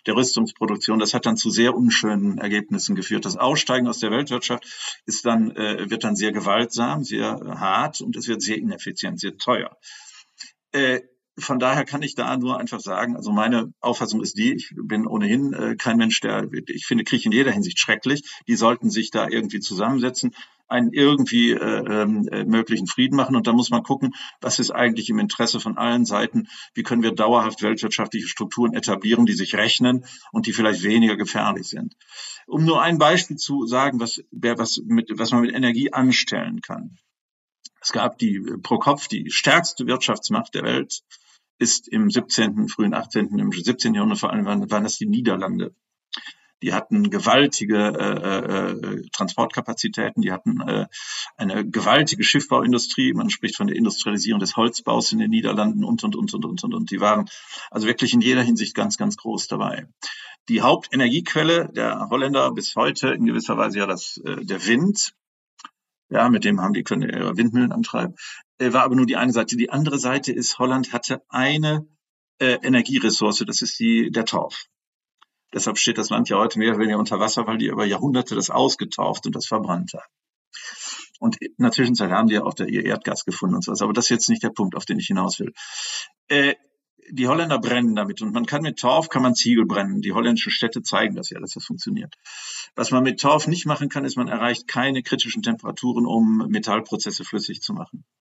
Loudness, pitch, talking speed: -21 LUFS, 130 Hz, 190 wpm